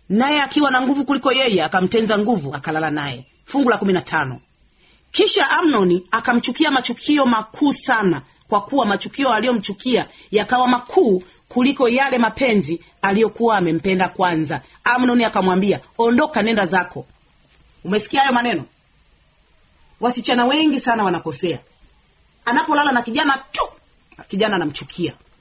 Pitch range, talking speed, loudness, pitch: 175-255 Hz, 120 wpm, -18 LUFS, 220 Hz